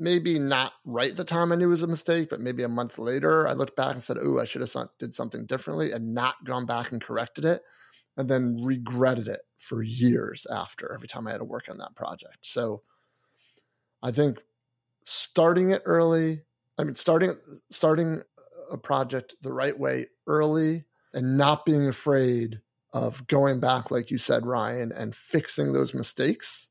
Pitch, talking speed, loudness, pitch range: 130 Hz, 185 wpm, -27 LUFS, 120-160 Hz